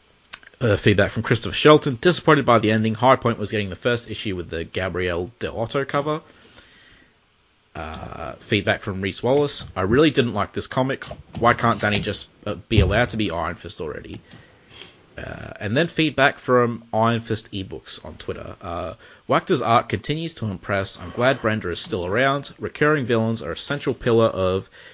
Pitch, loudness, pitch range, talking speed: 115 Hz, -21 LUFS, 100-135 Hz, 175 wpm